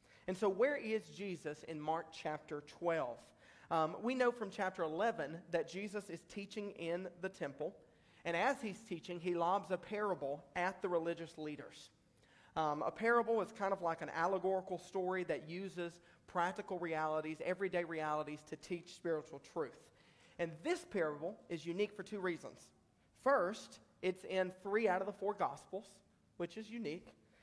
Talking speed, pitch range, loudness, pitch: 160 wpm, 165-200 Hz, -40 LUFS, 180 Hz